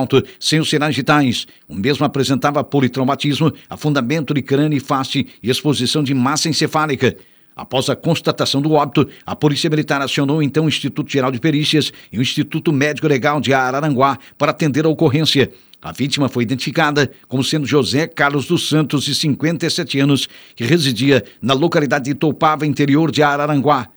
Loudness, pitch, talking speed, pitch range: -16 LUFS, 145 Hz, 165 wpm, 135-155 Hz